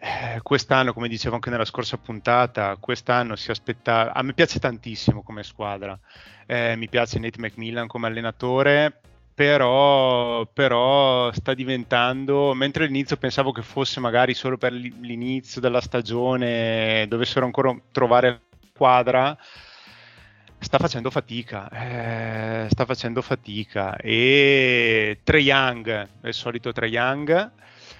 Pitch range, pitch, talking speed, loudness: 115-130 Hz, 120 Hz, 125 wpm, -22 LUFS